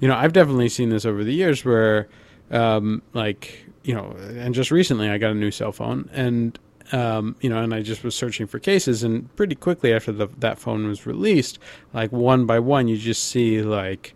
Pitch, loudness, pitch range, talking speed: 115 Hz, -21 LUFS, 110-125 Hz, 215 wpm